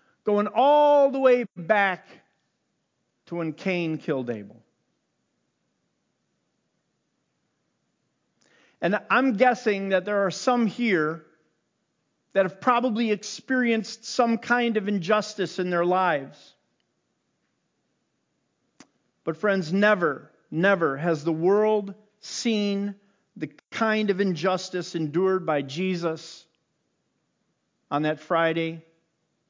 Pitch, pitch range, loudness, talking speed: 195 Hz, 165-215 Hz, -24 LUFS, 95 wpm